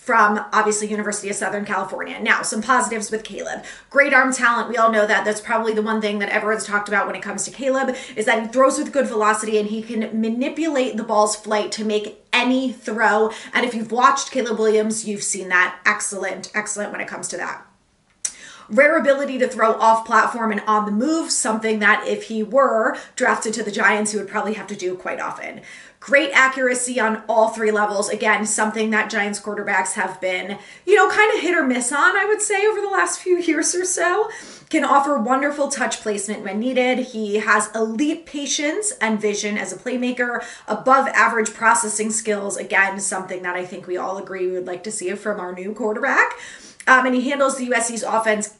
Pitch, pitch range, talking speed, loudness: 220 Hz, 210-260 Hz, 205 wpm, -19 LUFS